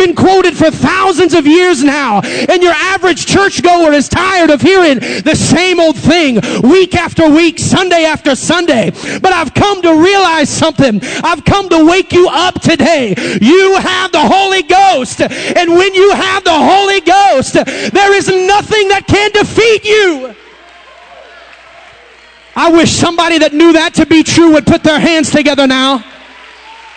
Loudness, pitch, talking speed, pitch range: -8 LUFS, 340 Hz, 160 wpm, 310-380 Hz